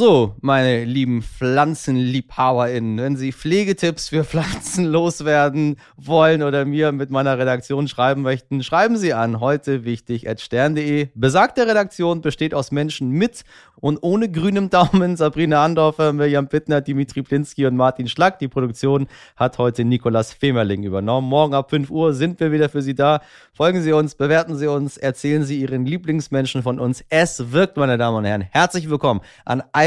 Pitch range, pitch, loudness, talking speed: 130-155 Hz, 140 Hz, -19 LUFS, 160 wpm